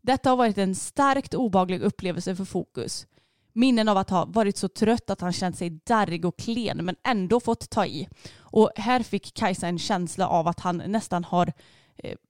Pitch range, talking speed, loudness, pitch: 180-230 Hz, 195 wpm, -25 LUFS, 195 Hz